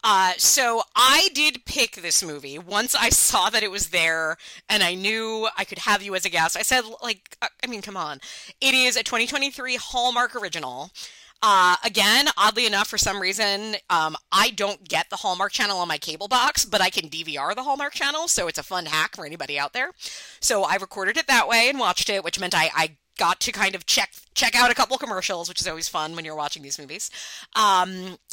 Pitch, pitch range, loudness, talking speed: 200 Hz, 175-245 Hz, -21 LUFS, 220 wpm